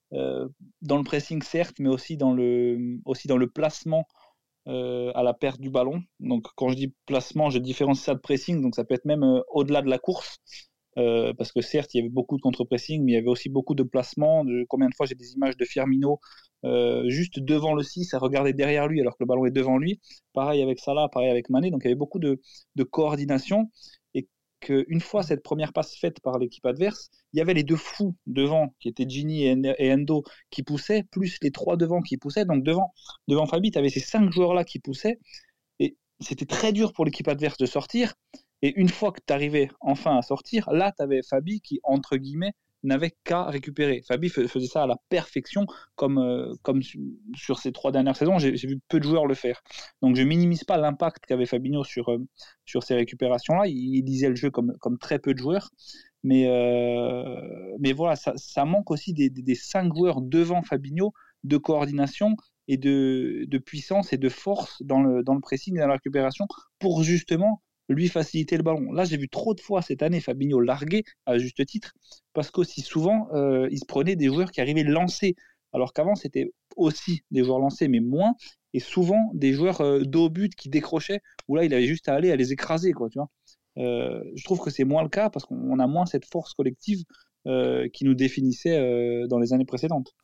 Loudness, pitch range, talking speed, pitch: -25 LUFS, 130-170 Hz, 220 wpm, 140 Hz